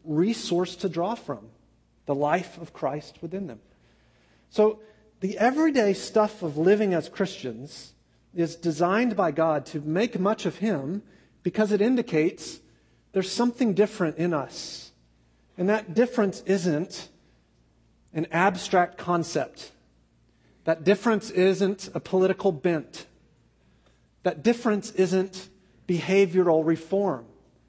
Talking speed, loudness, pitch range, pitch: 115 wpm, -26 LUFS, 155-200 Hz, 180 Hz